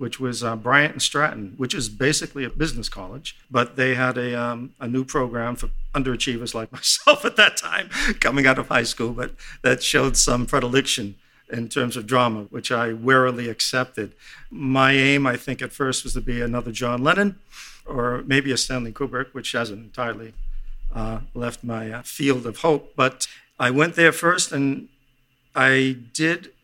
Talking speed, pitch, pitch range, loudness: 180 wpm, 125 Hz, 120-135 Hz, -21 LUFS